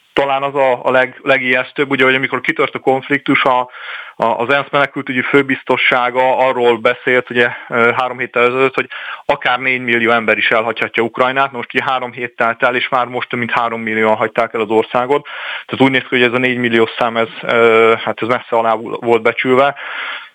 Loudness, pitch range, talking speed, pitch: -14 LUFS, 115-130 Hz, 190 wpm, 125 Hz